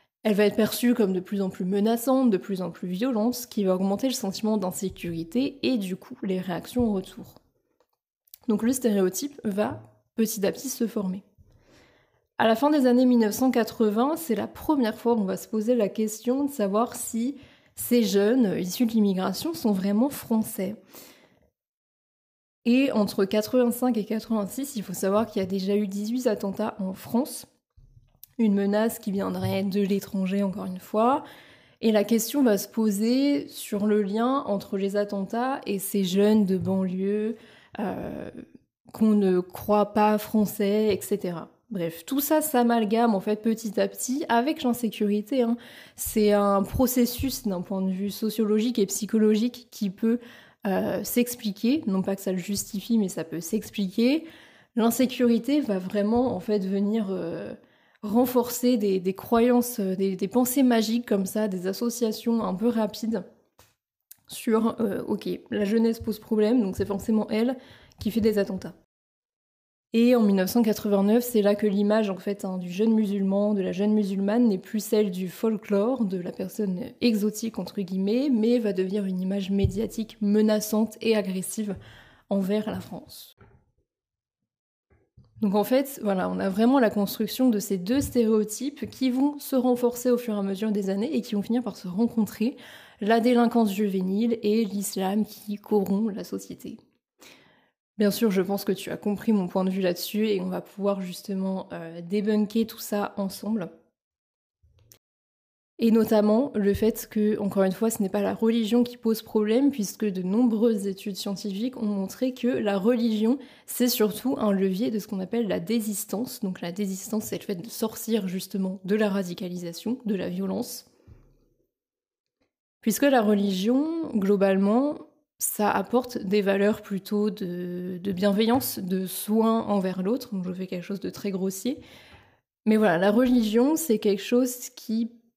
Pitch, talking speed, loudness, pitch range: 215 Hz, 165 wpm, -25 LUFS, 200-235 Hz